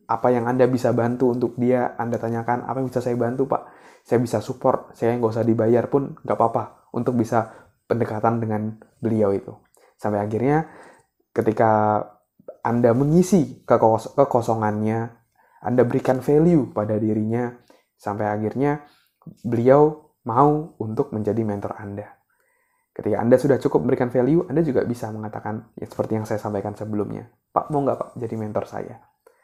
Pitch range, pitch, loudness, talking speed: 110-130 Hz, 120 Hz, -22 LUFS, 155 wpm